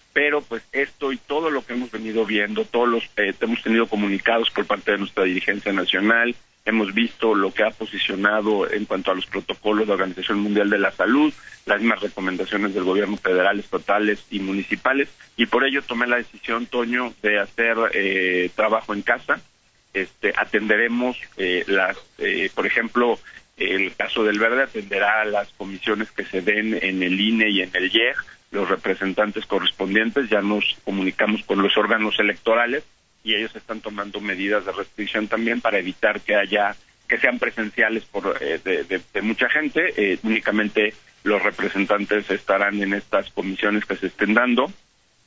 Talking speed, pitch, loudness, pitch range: 170 wpm, 110 Hz, -21 LUFS, 100-115 Hz